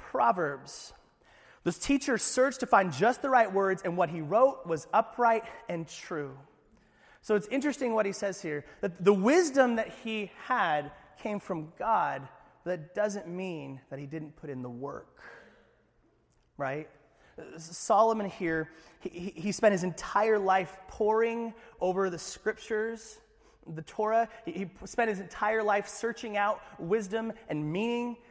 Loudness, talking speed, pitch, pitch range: -30 LUFS, 150 wpm, 205 Hz, 170-225 Hz